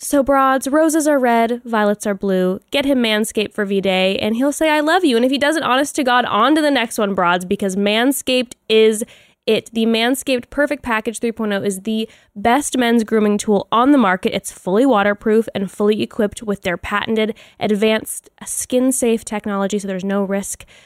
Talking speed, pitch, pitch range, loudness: 195 wpm, 225 Hz, 205-260 Hz, -17 LUFS